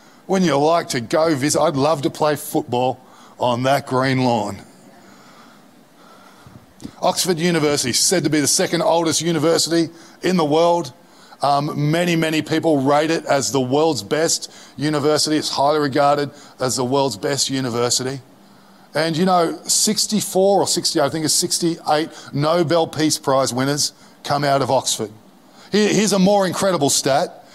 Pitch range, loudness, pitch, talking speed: 140-170 Hz, -18 LUFS, 155 Hz, 150 wpm